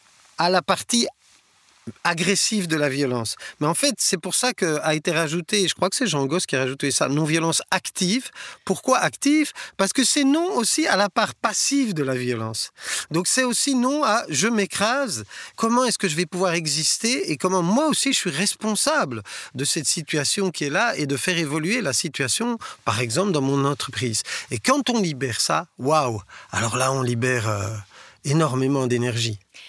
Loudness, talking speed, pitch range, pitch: -22 LUFS, 190 wpm, 135-220 Hz, 170 Hz